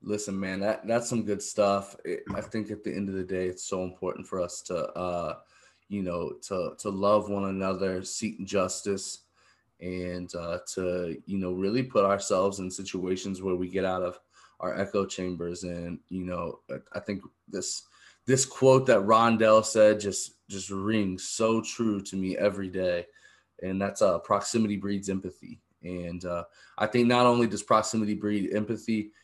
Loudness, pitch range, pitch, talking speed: -28 LUFS, 90-105 Hz, 100 Hz, 175 wpm